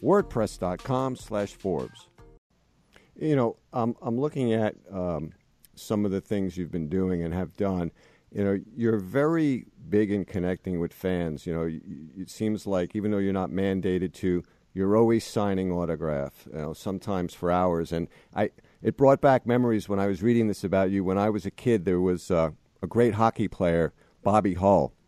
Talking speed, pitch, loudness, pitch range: 180 wpm, 100 Hz, -27 LUFS, 90-110 Hz